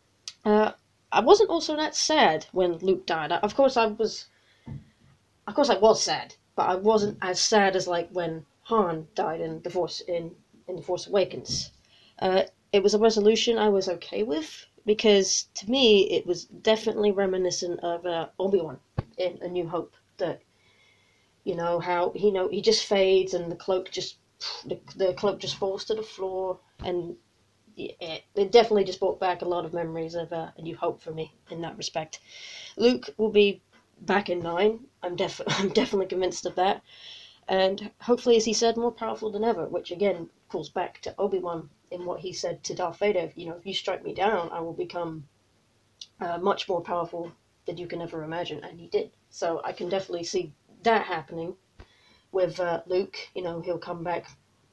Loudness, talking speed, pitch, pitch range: -26 LUFS, 195 wpm, 185 Hz, 170-210 Hz